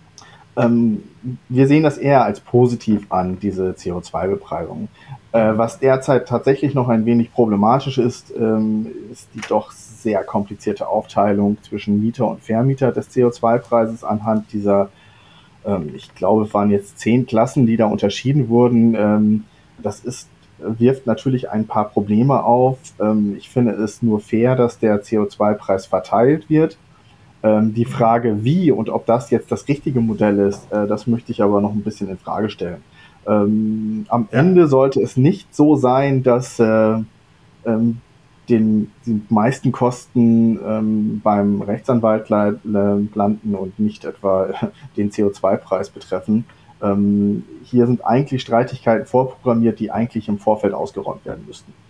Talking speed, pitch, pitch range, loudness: 145 wpm, 115 Hz, 105-125 Hz, -18 LUFS